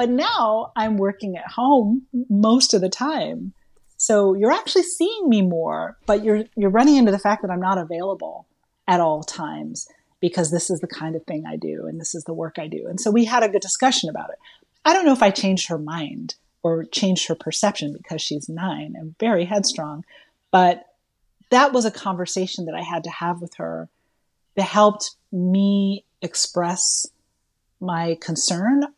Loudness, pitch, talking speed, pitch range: -21 LUFS, 190 Hz, 190 wpm, 165-220 Hz